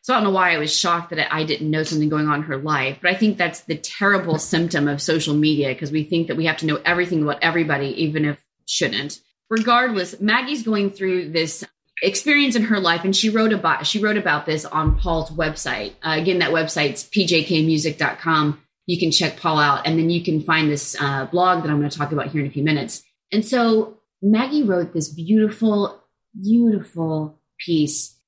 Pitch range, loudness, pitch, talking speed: 150-200 Hz, -20 LUFS, 165 Hz, 210 wpm